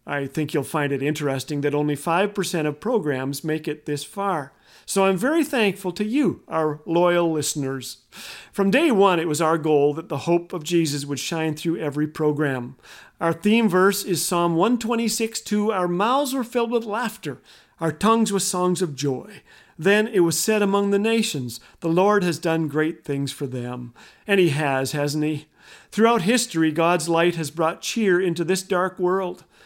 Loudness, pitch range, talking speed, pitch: -22 LUFS, 150-200 Hz, 185 wpm, 170 Hz